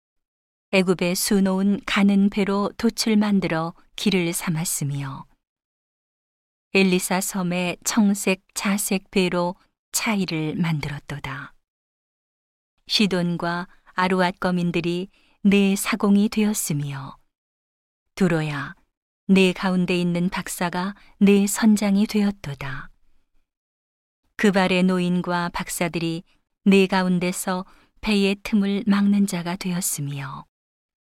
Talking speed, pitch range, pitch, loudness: 205 characters per minute, 170-200 Hz, 185 Hz, -22 LUFS